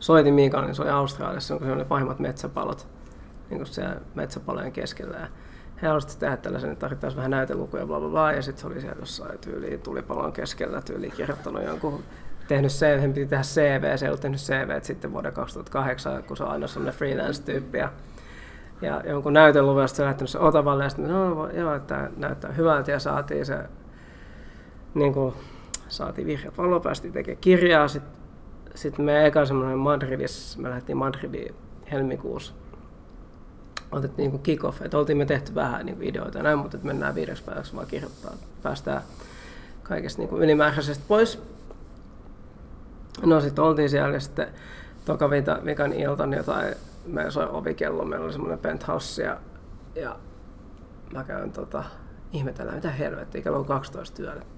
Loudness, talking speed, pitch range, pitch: -26 LUFS, 165 wpm, 135-155 Hz, 145 Hz